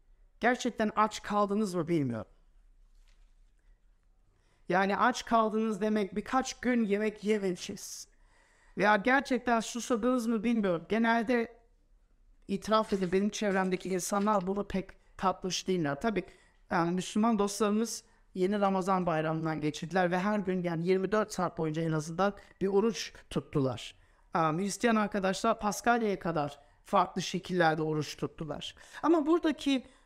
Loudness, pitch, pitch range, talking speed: -31 LUFS, 200 Hz, 180-225 Hz, 120 wpm